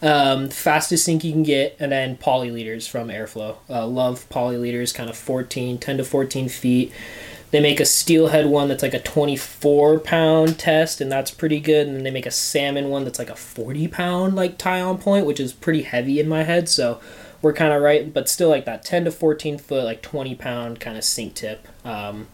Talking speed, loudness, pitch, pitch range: 220 wpm, -20 LUFS, 140 Hz, 125-155 Hz